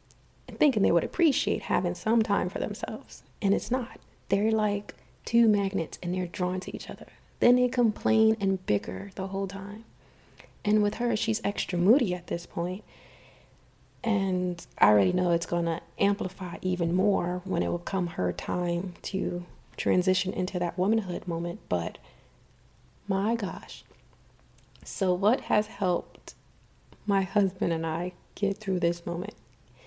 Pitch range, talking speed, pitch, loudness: 175-210 Hz, 155 wpm, 190 Hz, -28 LUFS